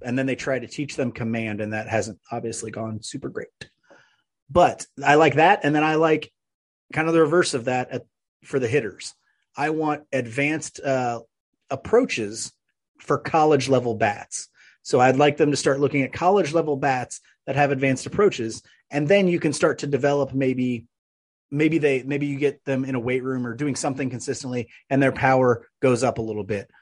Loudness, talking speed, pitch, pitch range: -22 LUFS, 195 wpm, 135 Hz, 120-145 Hz